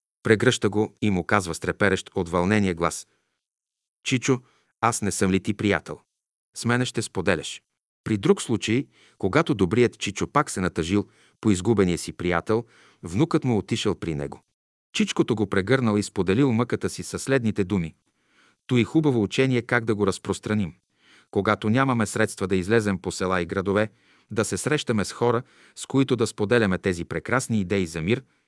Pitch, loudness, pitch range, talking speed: 105 Hz, -24 LUFS, 95-120 Hz, 165 wpm